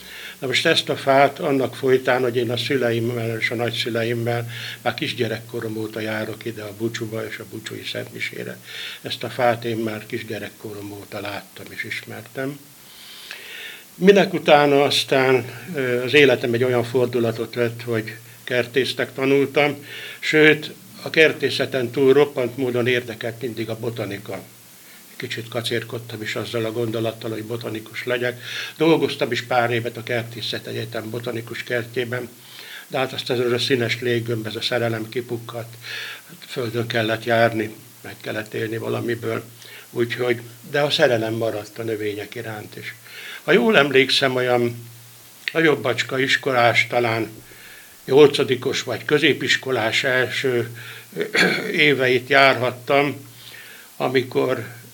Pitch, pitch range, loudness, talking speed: 120 Hz, 115-130 Hz, -21 LUFS, 125 wpm